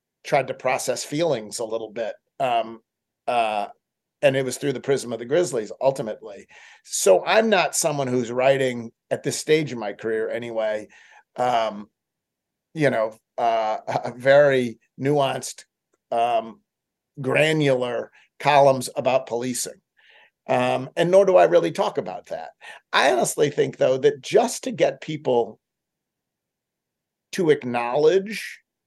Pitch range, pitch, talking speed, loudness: 115-150 Hz, 130 Hz, 135 wpm, -22 LUFS